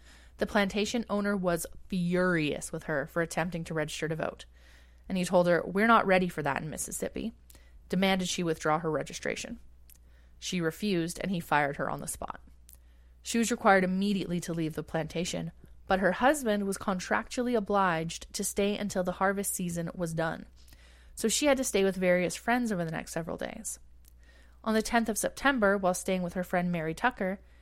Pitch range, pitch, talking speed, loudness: 150-200 Hz, 175 Hz, 185 wpm, -30 LUFS